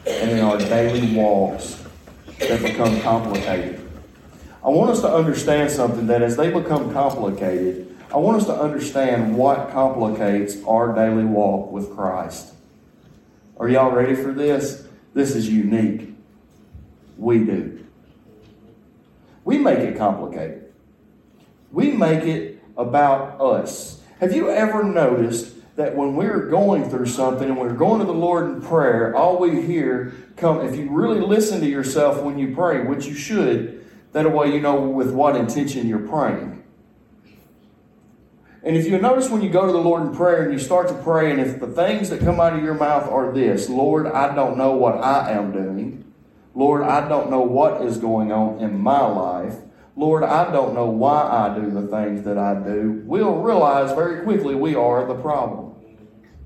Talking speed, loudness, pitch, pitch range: 170 wpm, -20 LUFS, 130 Hz, 110-150 Hz